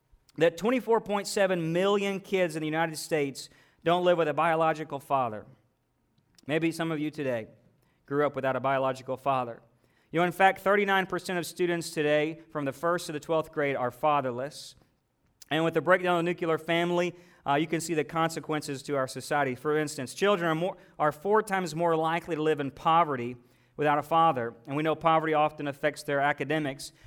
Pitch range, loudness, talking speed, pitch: 140-170 Hz, -28 LUFS, 185 wpm, 155 Hz